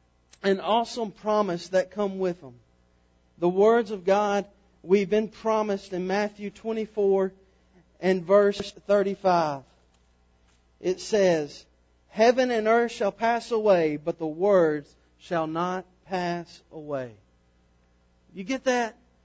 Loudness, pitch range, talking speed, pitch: -25 LUFS, 145-205 Hz, 120 wpm, 185 Hz